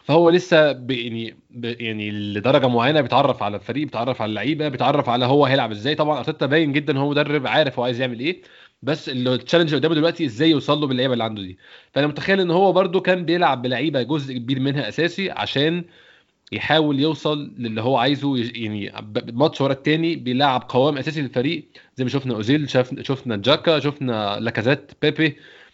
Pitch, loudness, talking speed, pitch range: 140 Hz, -20 LUFS, 175 wpm, 125-155 Hz